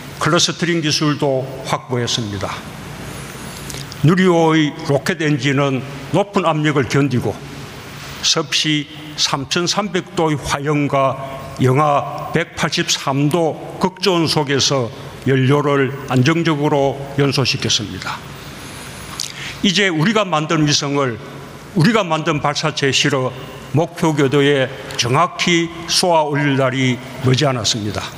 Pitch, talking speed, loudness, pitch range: 145 Hz, 220 characters per minute, -17 LUFS, 135-160 Hz